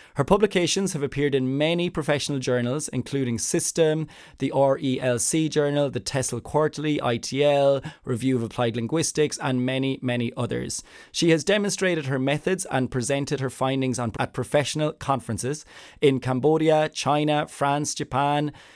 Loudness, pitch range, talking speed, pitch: -24 LUFS, 130-155 Hz, 140 wpm, 140 Hz